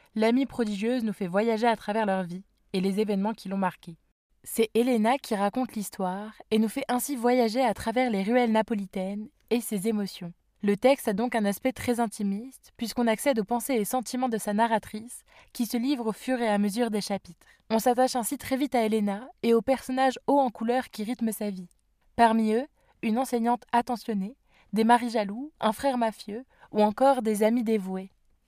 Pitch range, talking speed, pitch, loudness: 210-250 Hz, 195 wpm, 225 Hz, -27 LUFS